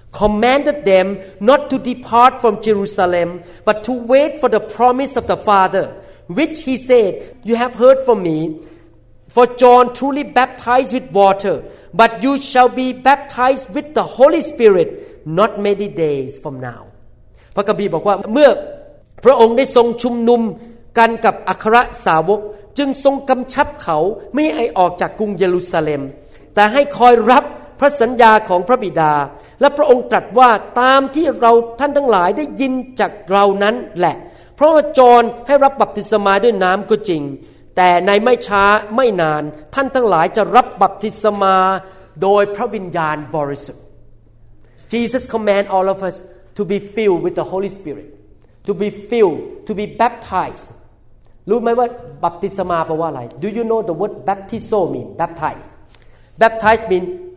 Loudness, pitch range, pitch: -14 LUFS, 180-250 Hz, 210 Hz